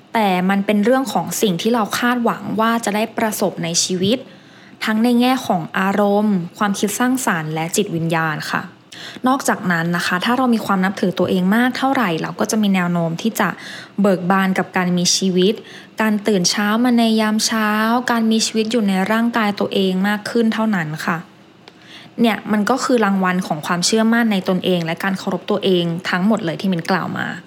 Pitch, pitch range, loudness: 205 Hz, 185-225 Hz, -18 LUFS